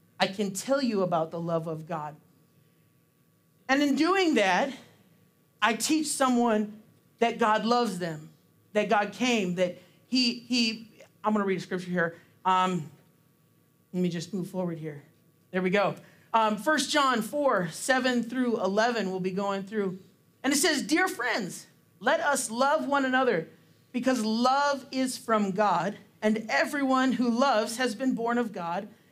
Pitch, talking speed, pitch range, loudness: 215 Hz, 160 wpm, 180-255 Hz, -27 LUFS